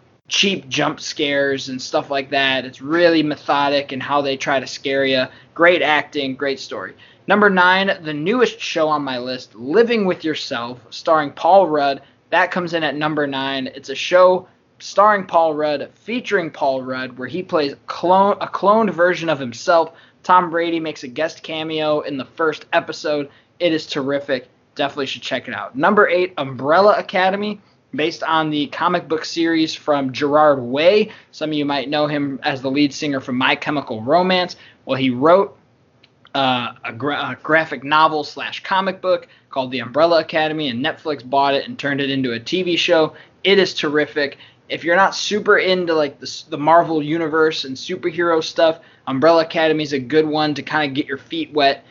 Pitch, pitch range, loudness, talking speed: 150 Hz, 140-170 Hz, -18 LUFS, 185 wpm